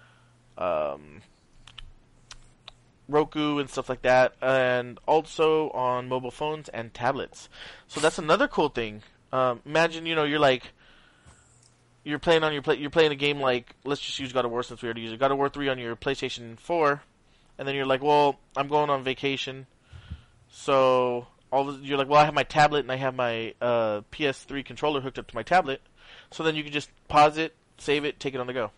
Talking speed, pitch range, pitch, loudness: 205 wpm, 125-150 Hz, 135 Hz, -26 LUFS